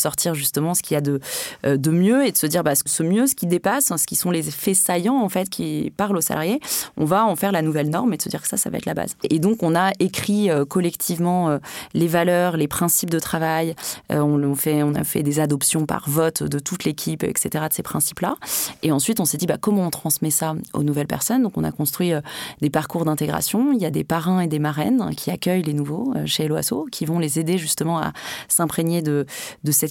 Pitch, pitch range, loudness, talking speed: 165 Hz, 150-185 Hz, -21 LUFS, 245 wpm